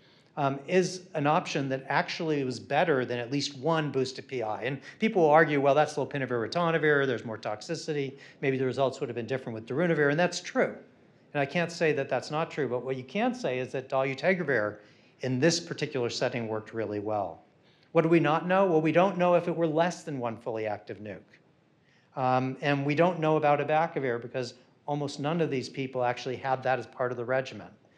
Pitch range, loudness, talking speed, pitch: 125-160 Hz, -28 LUFS, 210 wpm, 140 Hz